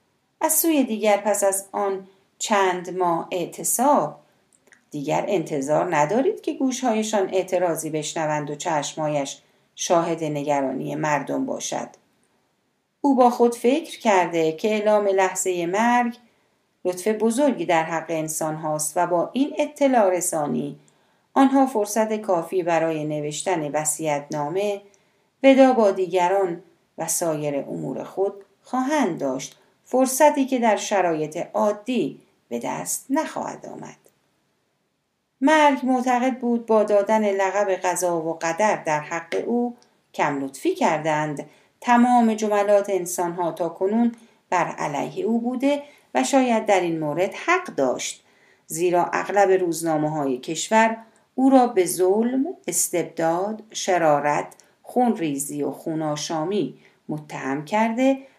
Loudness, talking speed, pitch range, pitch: -22 LUFS, 120 wpm, 165-240 Hz, 195 Hz